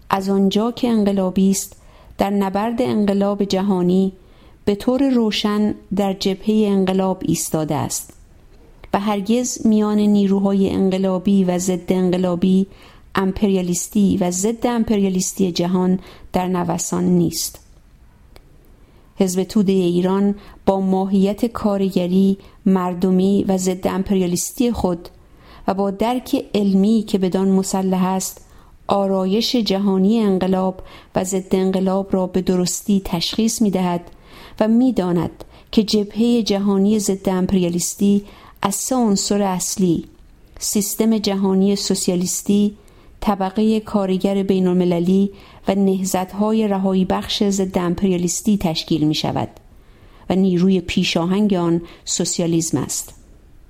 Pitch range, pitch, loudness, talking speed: 185-205 Hz, 195 Hz, -19 LUFS, 110 wpm